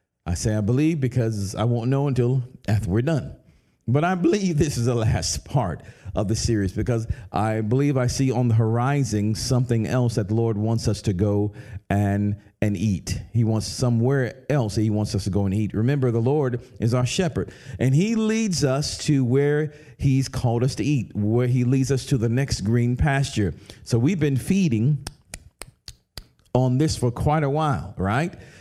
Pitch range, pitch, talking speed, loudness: 110-135 Hz, 120 Hz, 195 wpm, -23 LUFS